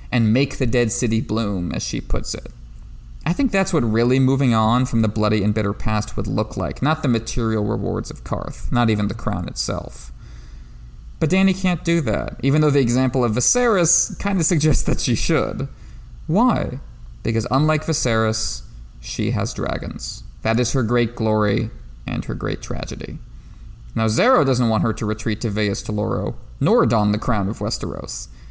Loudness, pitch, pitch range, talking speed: -20 LUFS, 115 Hz, 105-130 Hz, 180 wpm